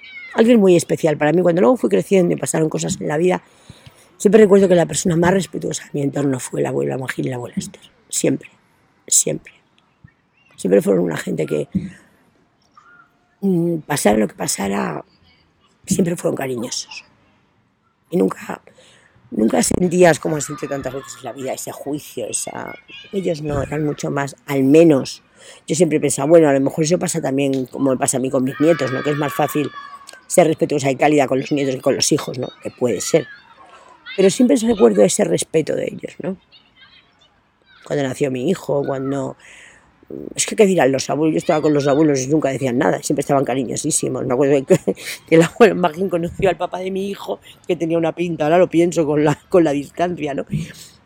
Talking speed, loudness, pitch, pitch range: 190 wpm, -18 LUFS, 160 Hz, 140-180 Hz